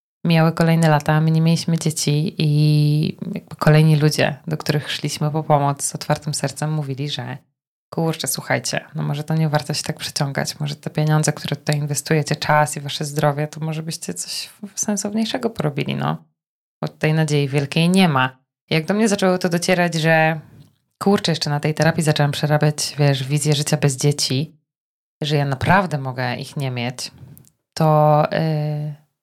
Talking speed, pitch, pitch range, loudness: 170 wpm, 150 Hz, 145-160 Hz, -19 LUFS